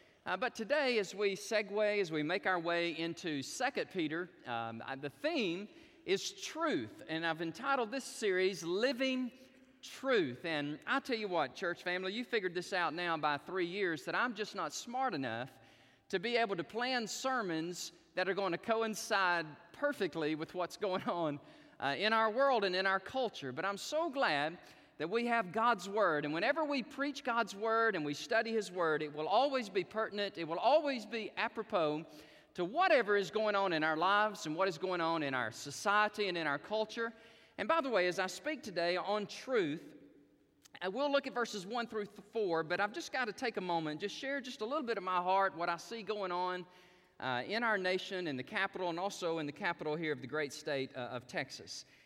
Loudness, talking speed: -36 LUFS, 210 wpm